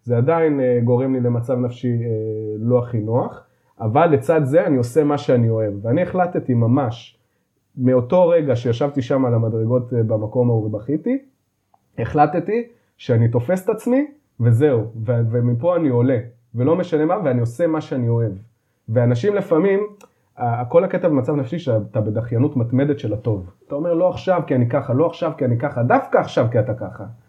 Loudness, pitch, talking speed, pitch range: -19 LUFS, 125 Hz, 165 wpm, 115-155 Hz